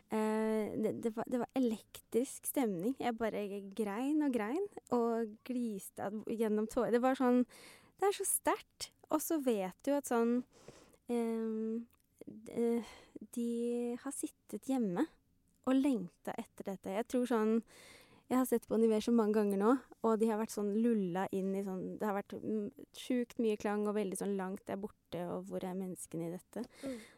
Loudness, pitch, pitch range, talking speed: -36 LUFS, 230 Hz, 210-250 Hz, 170 wpm